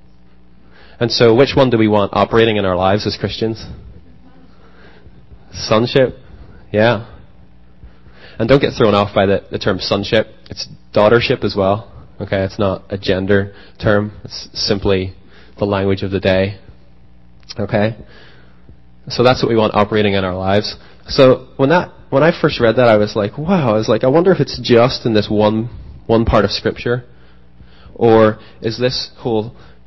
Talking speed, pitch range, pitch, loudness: 165 wpm, 90-115 Hz, 100 Hz, -15 LUFS